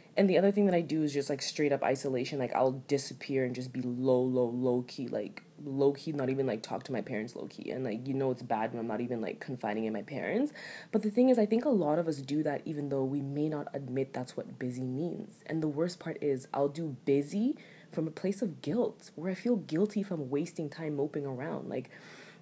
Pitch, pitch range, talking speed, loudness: 145 Hz, 130-165 Hz, 255 wpm, -33 LUFS